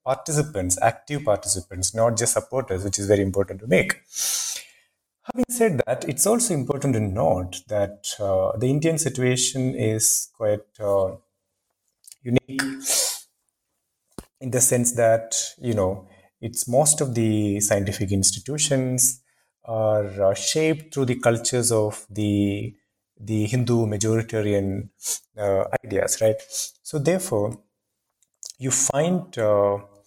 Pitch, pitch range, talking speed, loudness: 115 Hz, 100-135 Hz, 120 wpm, -22 LUFS